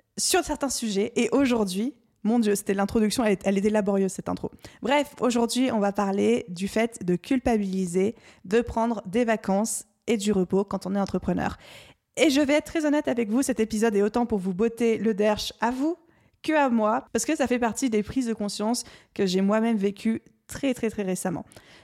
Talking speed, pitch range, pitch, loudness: 200 wpm, 200-245 Hz, 225 Hz, -25 LUFS